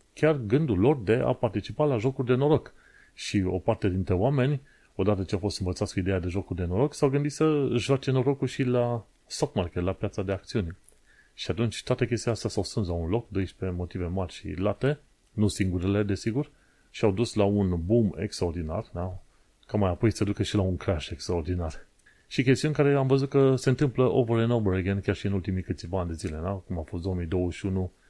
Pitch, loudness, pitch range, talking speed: 105 Hz, -27 LUFS, 95-125 Hz, 205 wpm